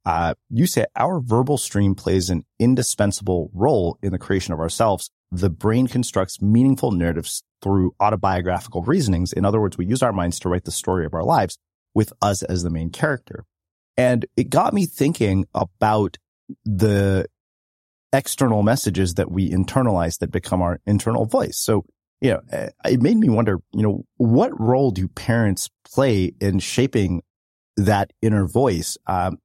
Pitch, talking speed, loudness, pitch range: 100 Hz, 165 wpm, -21 LUFS, 90-115 Hz